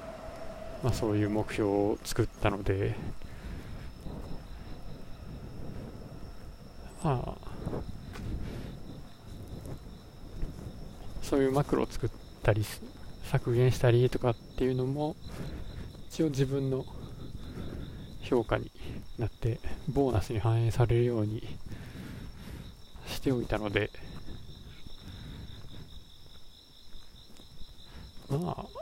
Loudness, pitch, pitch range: -32 LUFS, 115 Hz, 105-130 Hz